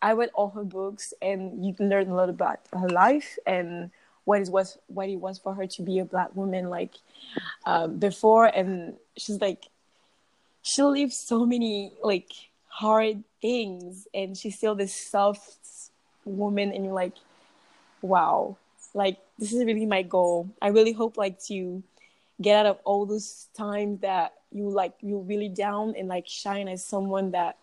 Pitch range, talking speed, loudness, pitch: 190-215 Hz, 175 wpm, -26 LUFS, 200 Hz